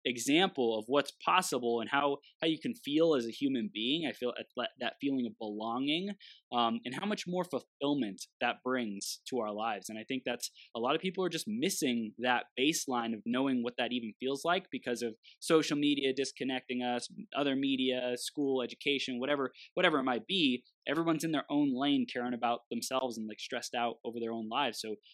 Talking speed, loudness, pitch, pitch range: 200 wpm, -33 LUFS, 130 Hz, 120-155 Hz